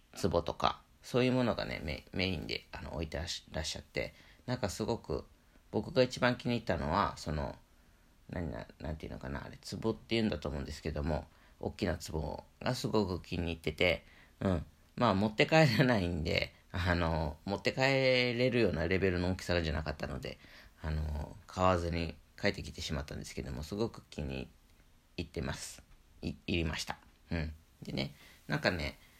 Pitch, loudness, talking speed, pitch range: 85 Hz, -35 LUFS, 350 characters per minute, 75-110 Hz